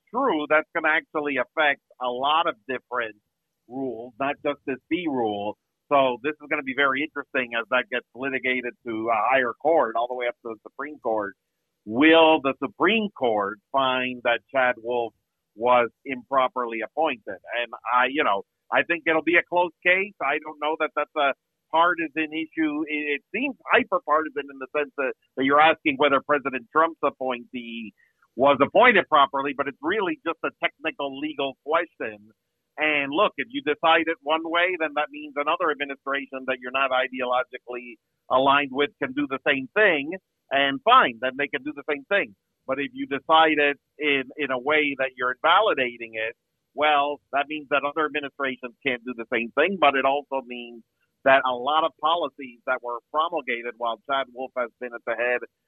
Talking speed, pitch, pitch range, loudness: 185 wpm, 140 Hz, 125-155 Hz, -24 LUFS